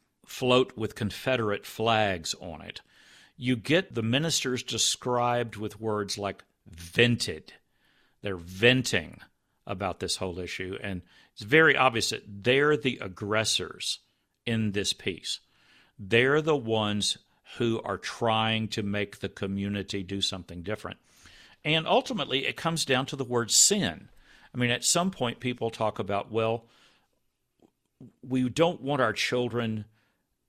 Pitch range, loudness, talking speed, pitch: 100-125 Hz, -27 LUFS, 135 wpm, 115 Hz